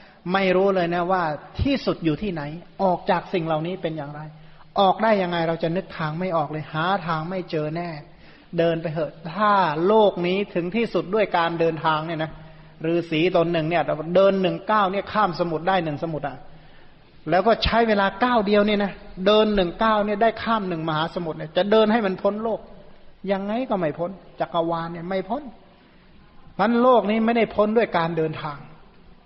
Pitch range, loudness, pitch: 165-205 Hz, -22 LUFS, 180 Hz